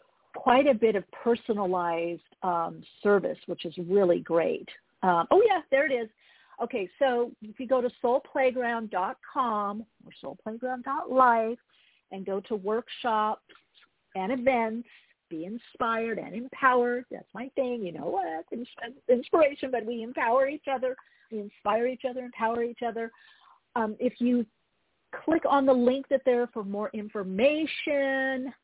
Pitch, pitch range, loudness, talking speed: 240 Hz, 210-265 Hz, -28 LUFS, 140 wpm